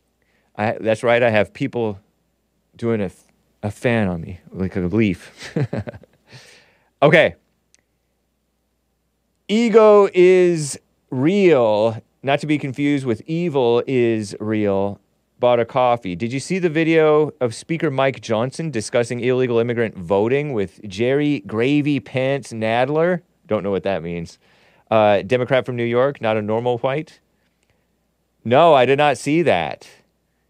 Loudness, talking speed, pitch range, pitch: -18 LUFS, 135 wpm, 105-145 Hz, 120 Hz